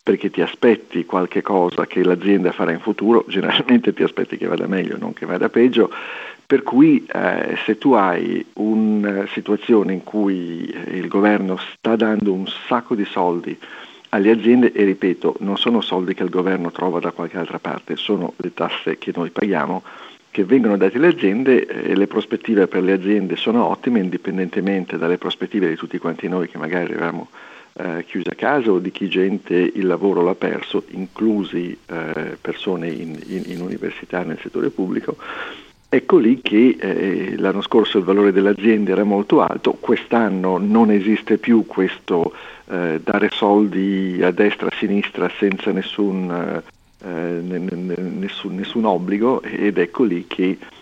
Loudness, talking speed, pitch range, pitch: -19 LUFS, 165 wpm, 90-105 Hz, 95 Hz